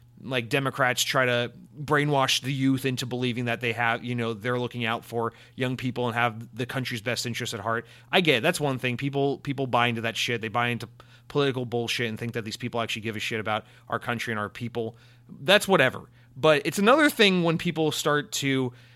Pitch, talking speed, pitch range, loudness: 125 Hz, 220 wpm, 120-135 Hz, -26 LUFS